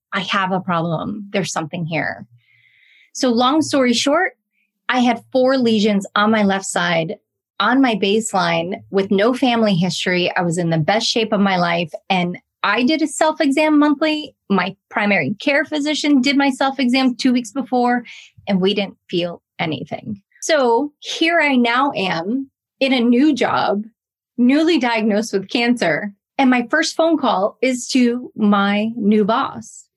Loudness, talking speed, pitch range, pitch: -17 LUFS, 160 wpm, 195-265 Hz, 225 Hz